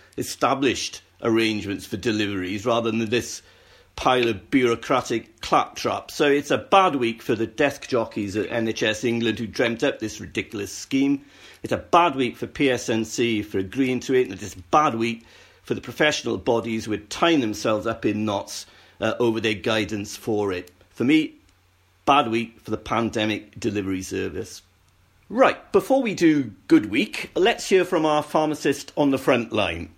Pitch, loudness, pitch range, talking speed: 115 Hz, -23 LUFS, 105-135 Hz, 170 wpm